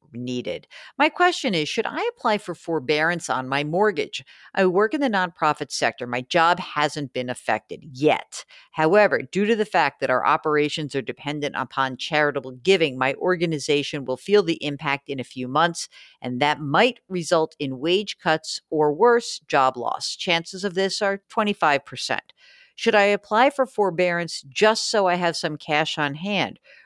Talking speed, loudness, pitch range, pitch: 170 wpm, -22 LUFS, 145-205 Hz, 165 Hz